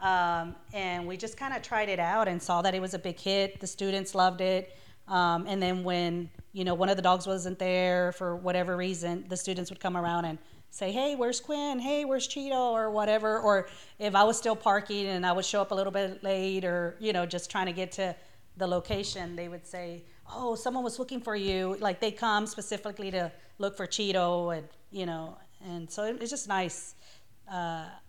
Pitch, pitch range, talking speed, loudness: 190 Hz, 175-210 Hz, 220 wpm, -30 LUFS